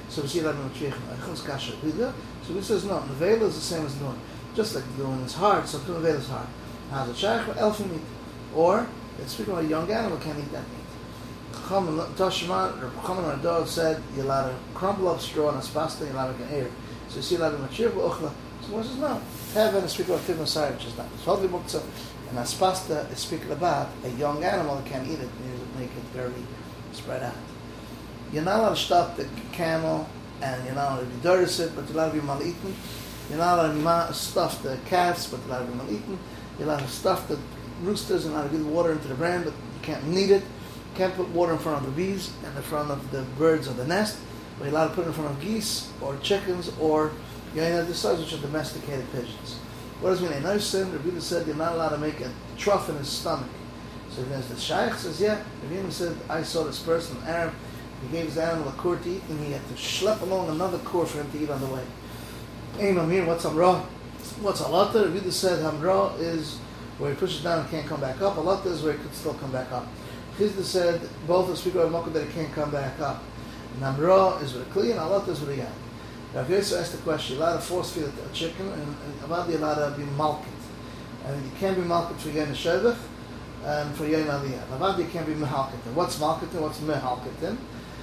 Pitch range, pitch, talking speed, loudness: 135-175 Hz, 155 Hz, 230 wpm, -27 LUFS